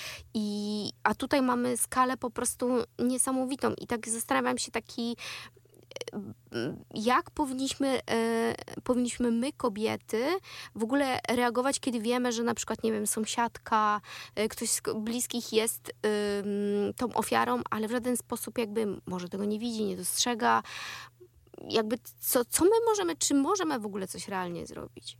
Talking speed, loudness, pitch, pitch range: 145 wpm, -30 LUFS, 235 Hz, 215-255 Hz